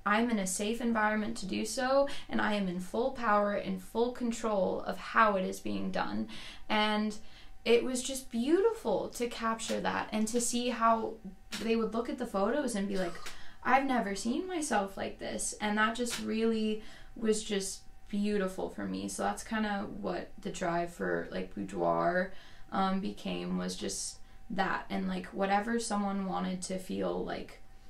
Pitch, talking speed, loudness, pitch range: 205 Hz, 175 wpm, -33 LUFS, 180-230 Hz